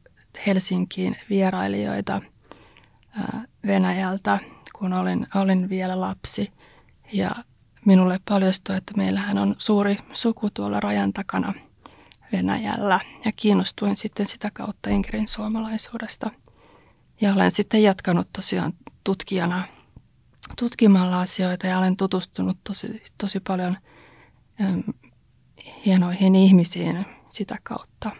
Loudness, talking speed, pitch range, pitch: -23 LUFS, 100 wpm, 180-210 Hz, 190 Hz